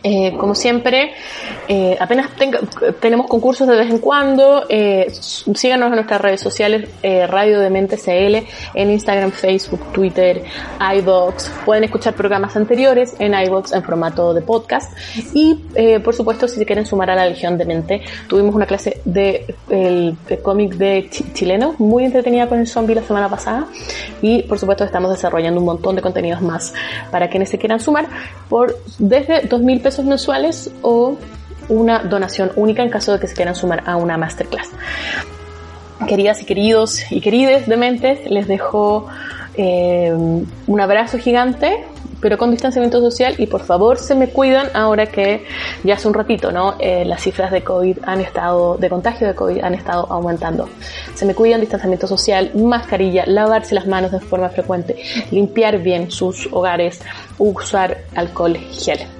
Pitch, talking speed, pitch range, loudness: 205 Hz, 165 wpm, 185-235 Hz, -16 LUFS